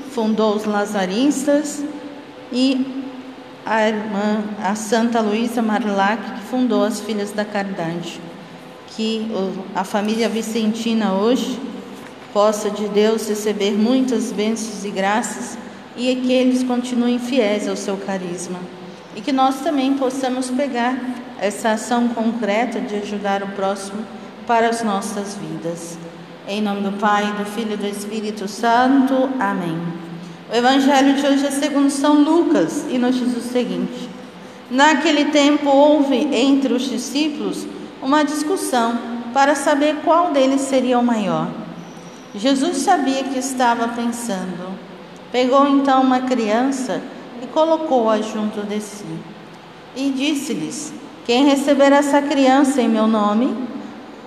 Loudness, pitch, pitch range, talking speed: -19 LUFS, 235 Hz, 210-265 Hz, 130 wpm